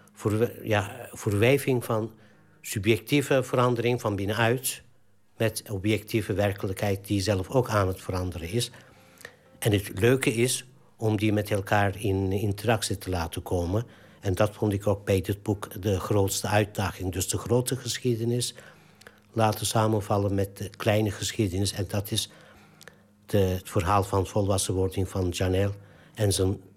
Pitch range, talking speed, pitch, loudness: 100-115 Hz, 140 wpm, 105 Hz, -27 LUFS